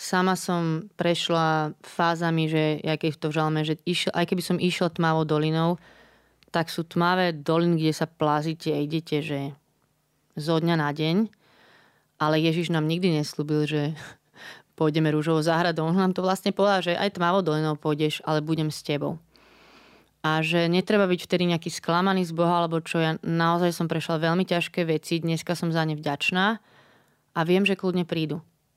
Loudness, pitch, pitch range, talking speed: -25 LUFS, 165 Hz, 155-175 Hz, 170 wpm